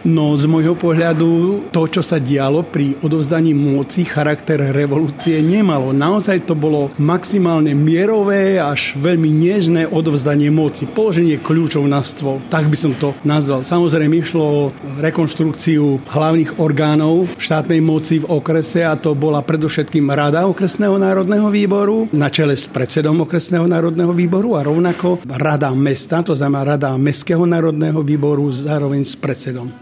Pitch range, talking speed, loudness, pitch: 145-170 Hz, 145 wpm, -15 LUFS, 155 Hz